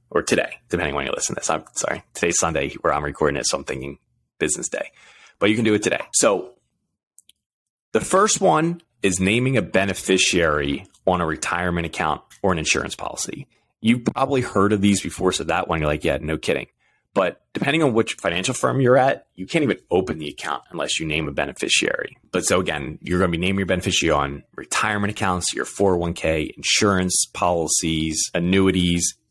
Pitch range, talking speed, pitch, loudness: 85-110 Hz, 195 wpm, 95 Hz, -21 LUFS